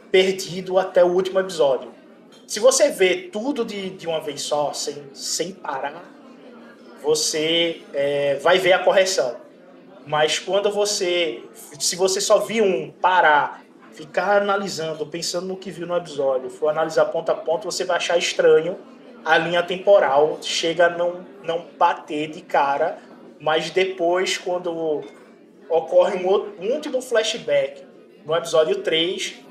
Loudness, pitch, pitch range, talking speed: -21 LUFS, 180 Hz, 160-195 Hz, 145 wpm